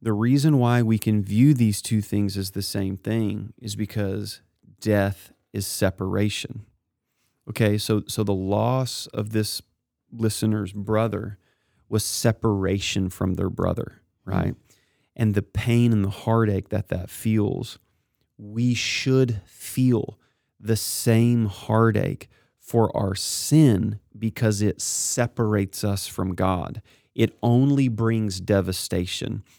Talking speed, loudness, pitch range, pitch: 125 wpm, -23 LUFS, 100-115 Hz, 110 Hz